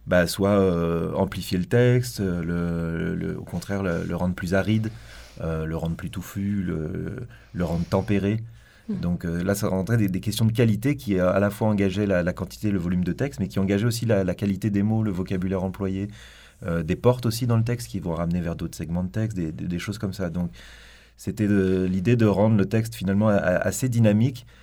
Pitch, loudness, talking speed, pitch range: 95 Hz, -24 LUFS, 230 wpm, 90-110 Hz